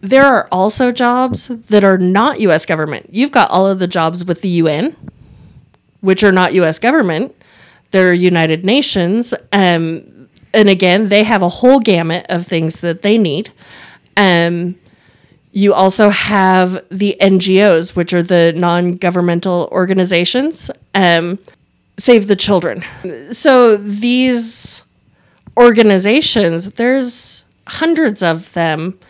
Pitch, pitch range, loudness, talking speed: 190 Hz, 175-220 Hz, -12 LUFS, 130 wpm